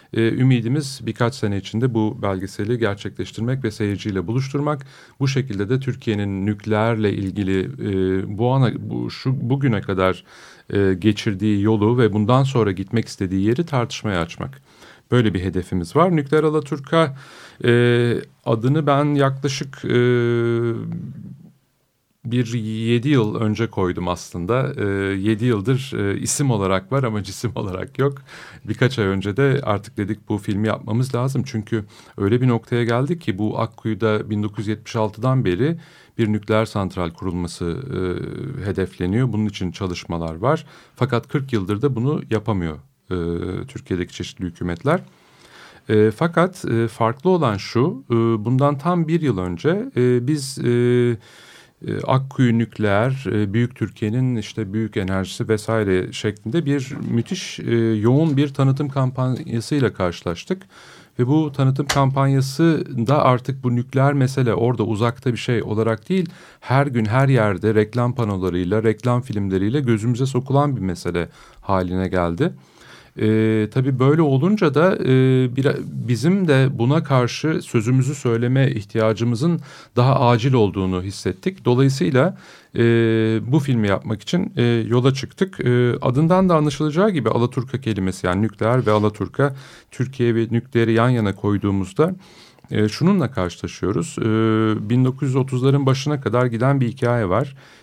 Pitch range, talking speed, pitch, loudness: 105-135 Hz, 135 wpm, 120 Hz, -20 LUFS